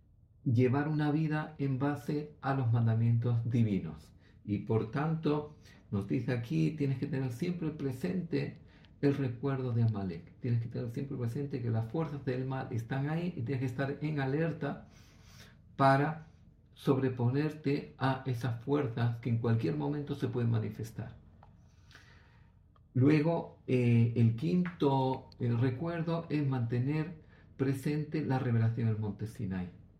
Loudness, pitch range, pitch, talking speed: -33 LUFS, 115-145 Hz, 130 Hz, 135 wpm